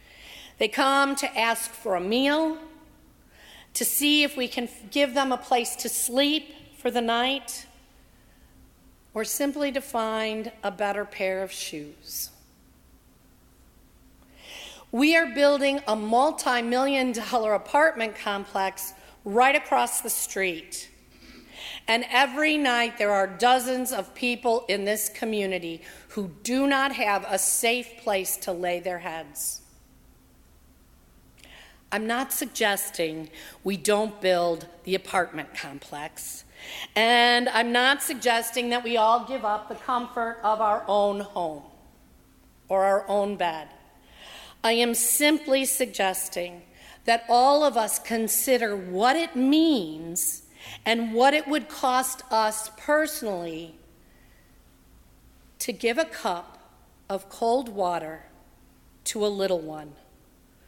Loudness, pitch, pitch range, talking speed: -25 LUFS, 225 Hz, 190-255 Hz, 120 wpm